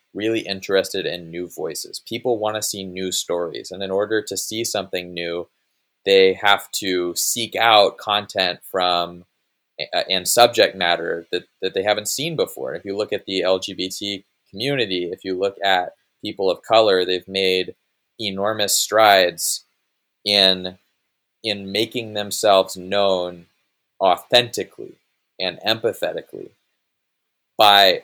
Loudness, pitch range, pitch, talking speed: -20 LUFS, 90-105 Hz, 95 Hz, 135 wpm